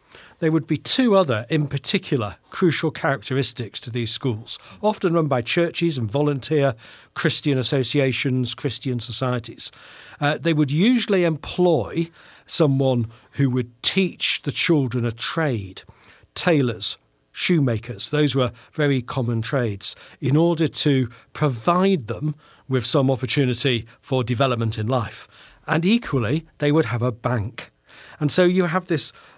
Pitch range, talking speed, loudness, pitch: 125-160 Hz, 135 wpm, -22 LUFS, 140 Hz